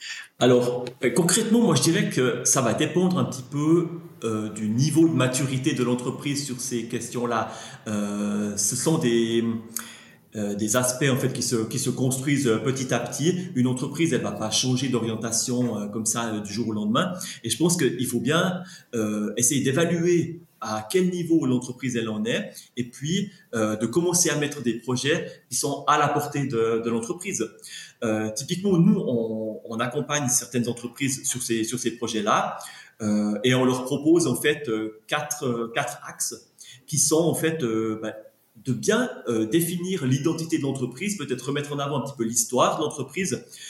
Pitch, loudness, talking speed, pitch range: 125 Hz, -24 LUFS, 185 wpm, 115-155 Hz